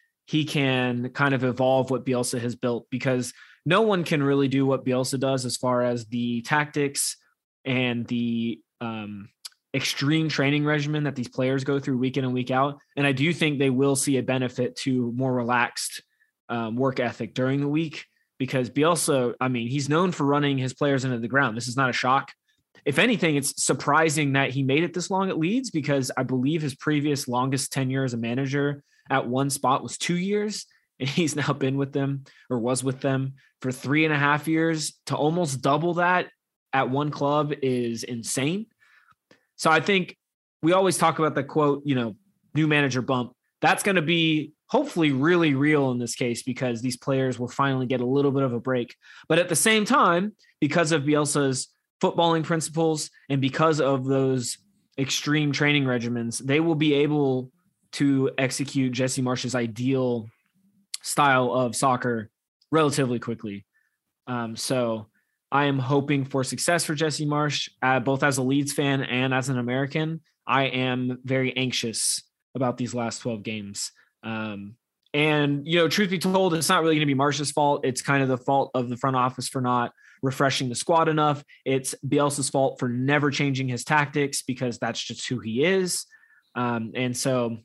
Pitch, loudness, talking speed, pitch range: 135 Hz, -24 LUFS, 185 wpm, 125-150 Hz